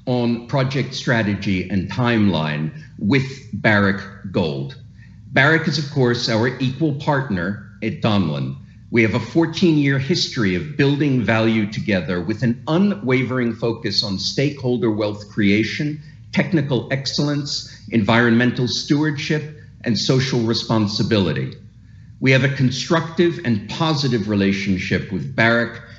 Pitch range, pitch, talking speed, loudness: 110-140 Hz, 120 Hz, 120 wpm, -19 LUFS